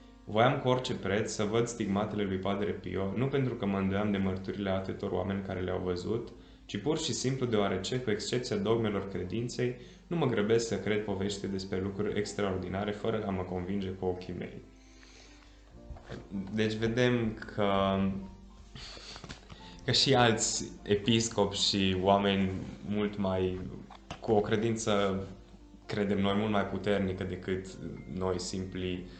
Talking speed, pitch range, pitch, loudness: 140 wpm, 95-110 Hz, 100 Hz, -31 LUFS